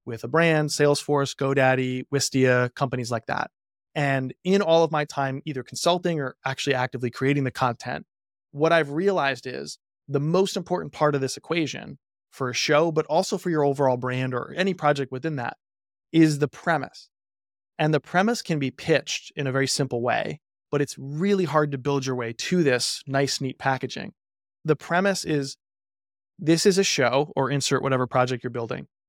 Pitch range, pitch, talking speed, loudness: 130-155 Hz, 140 Hz, 180 wpm, -24 LUFS